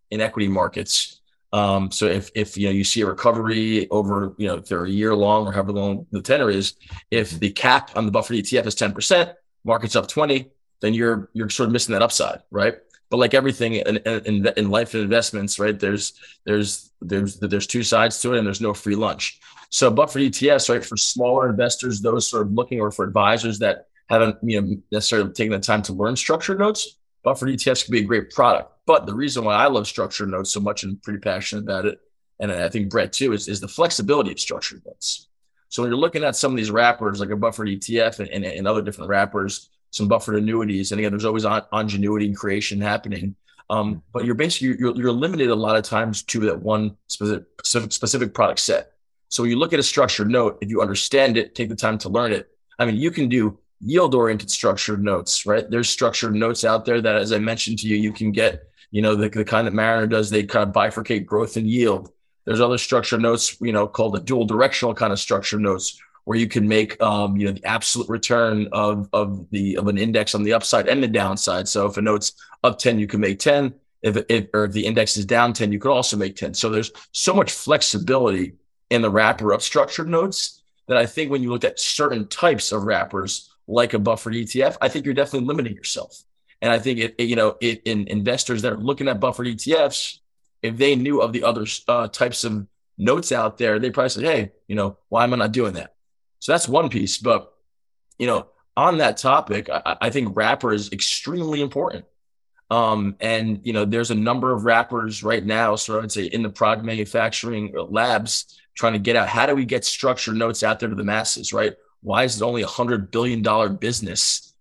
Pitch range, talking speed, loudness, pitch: 105-120 Hz, 225 wpm, -21 LUFS, 110 Hz